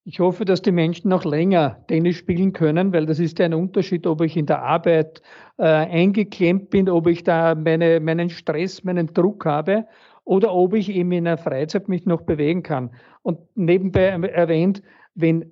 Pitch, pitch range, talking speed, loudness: 175 Hz, 165-185 Hz, 185 wpm, -20 LUFS